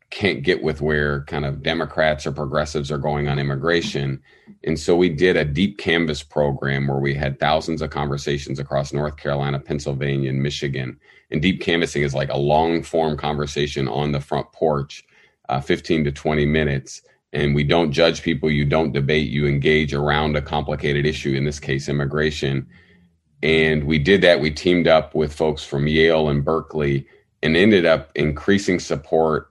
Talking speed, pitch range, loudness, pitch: 175 wpm, 70-80 Hz, -20 LUFS, 75 Hz